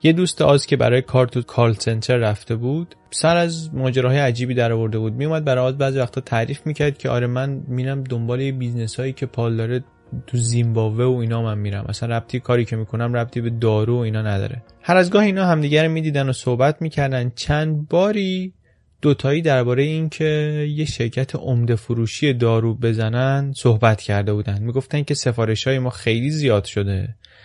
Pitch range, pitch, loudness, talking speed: 115-145 Hz, 125 Hz, -20 LUFS, 190 wpm